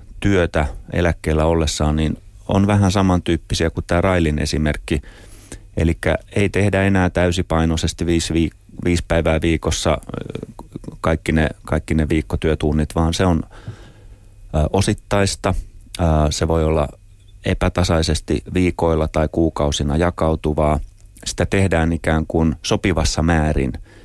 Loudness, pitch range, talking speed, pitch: -19 LUFS, 80-95 Hz, 110 wpm, 85 Hz